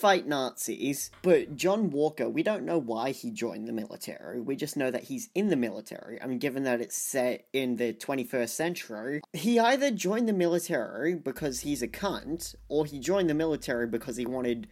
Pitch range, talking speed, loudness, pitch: 120-175 Hz, 195 wpm, -30 LUFS, 140 Hz